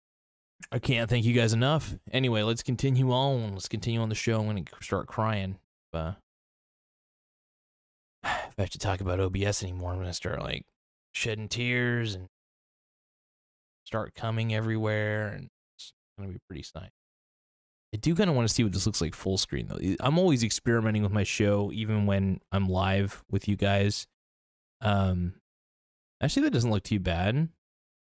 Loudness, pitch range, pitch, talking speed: -29 LUFS, 95-115 Hz, 105 Hz, 165 wpm